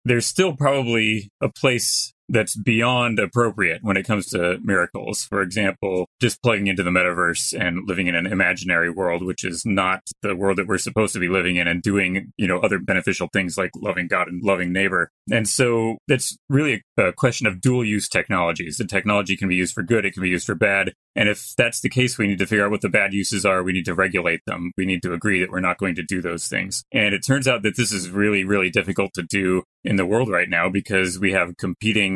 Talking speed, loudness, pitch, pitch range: 235 wpm, -21 LUFS, 100 Hz, 90-110 Hz